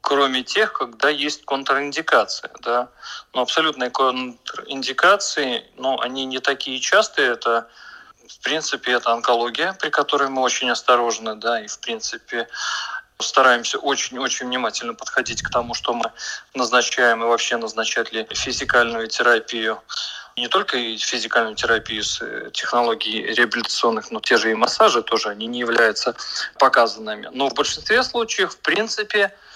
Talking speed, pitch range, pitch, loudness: 135 wpm, 115-140 Hz, 130 Hz, -20 LUFS